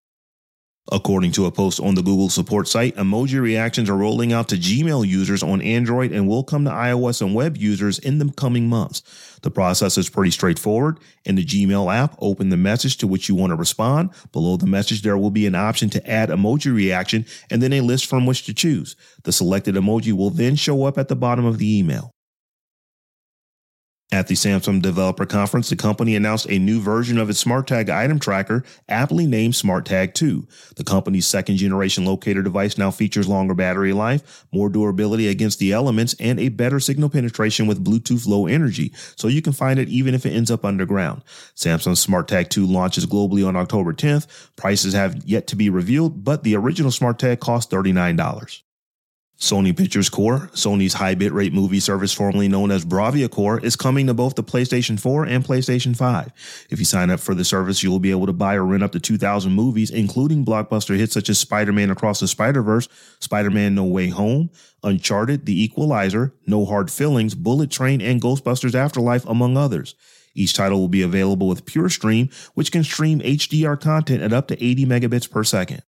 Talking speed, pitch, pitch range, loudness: 195 wpm, 110 Hz, 100-130 Hz, -19 LUFS